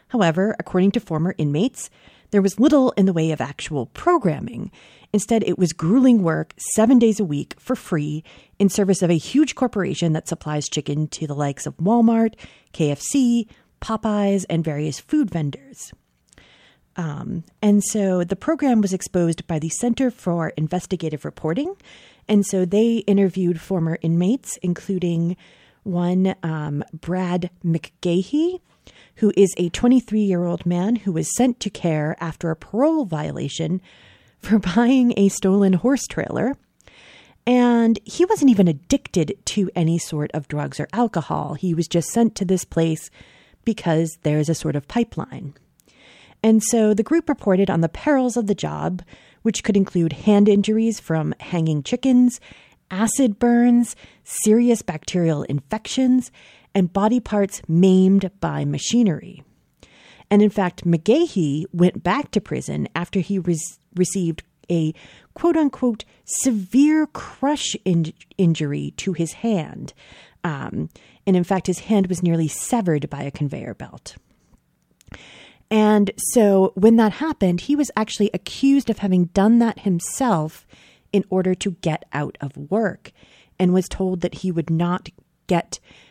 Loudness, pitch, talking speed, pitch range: -20 LUFS, 190 Hz, 145 wpm, 165-225 Hz